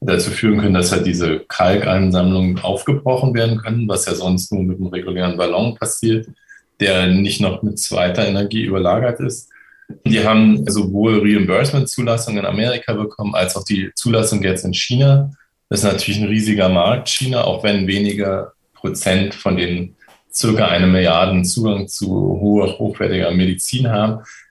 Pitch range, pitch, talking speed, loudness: 95-110 Hz, 100 Hz, 155 wpm, -16 LUFS